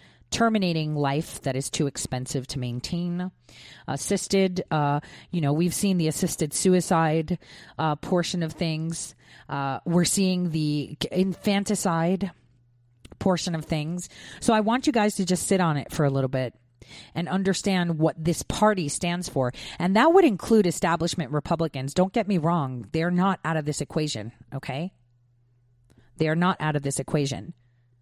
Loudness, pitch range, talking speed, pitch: -25 LUFS, 140-185 Hz, 160 wpm, 160 Hz